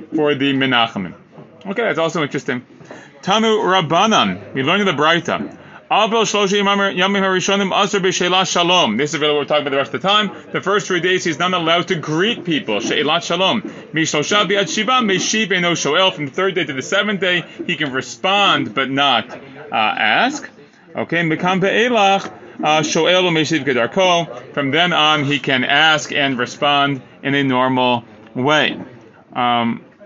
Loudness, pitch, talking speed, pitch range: -16 LUFS, 165 Hz, 130 wpm, 140-190 Hz